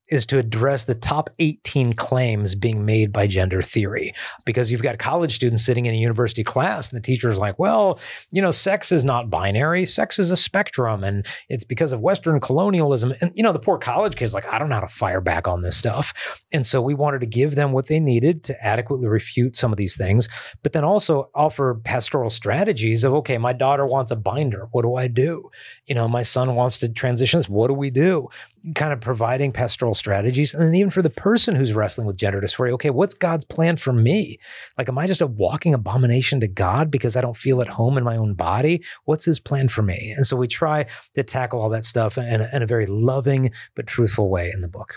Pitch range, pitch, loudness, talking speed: 115-150 Hz, 125 Hz, -20 LUFS, 230 wpm